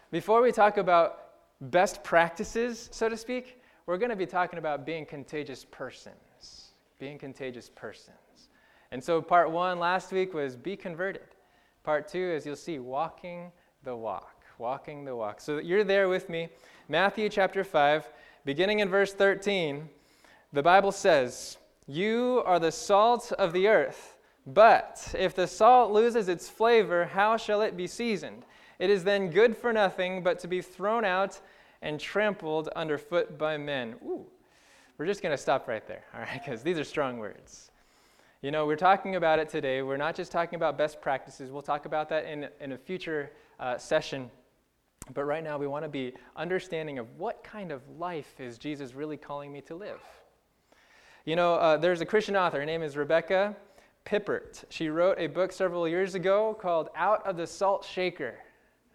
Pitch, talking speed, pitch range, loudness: 175 Hz, 180 wpm, 150-200 Hz, -28 LUFS